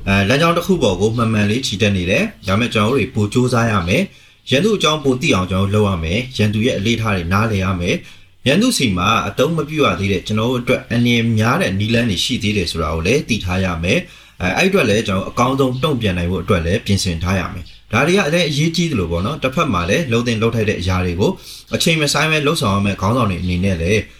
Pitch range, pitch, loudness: 95-130 Hz, 110 Hz, -16 LUFS